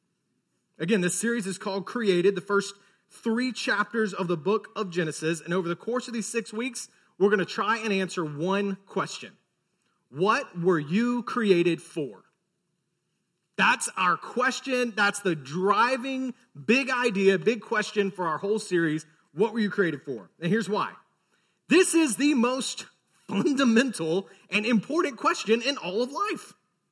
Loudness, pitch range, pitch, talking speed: -26 LUFS, 180-235 Hz, 205 Hz, 155 wpm